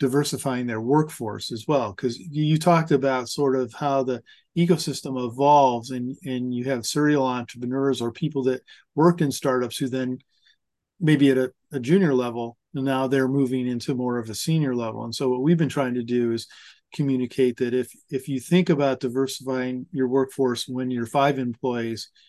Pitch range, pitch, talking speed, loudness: 125-140 Hz, 130 Hz, 180 wpm, -24 LUFS